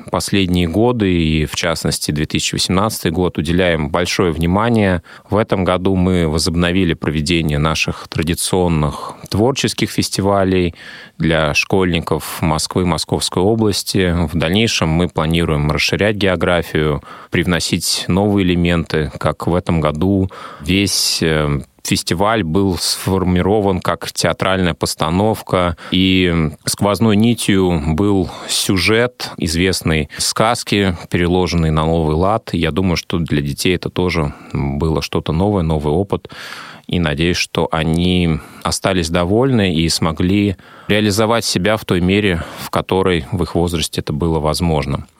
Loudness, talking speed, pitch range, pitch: -16 LUFS, 120 wpm, 80-95 Hz, 90 Hz